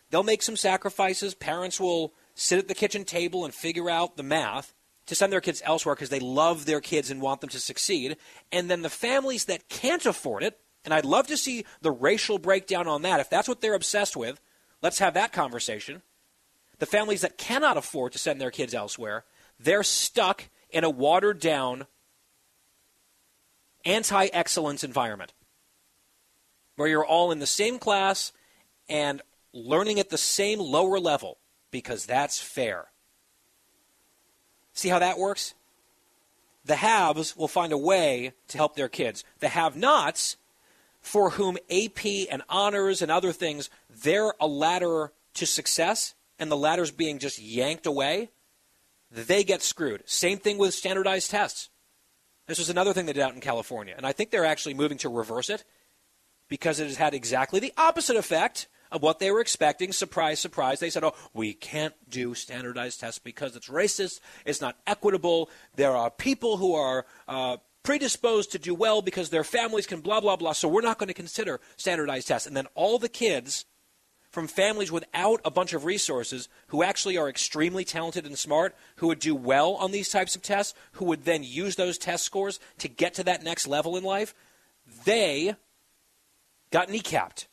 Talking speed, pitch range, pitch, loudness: 175 wpm, 150-195 Hz, 175 Hz, -27 LUFS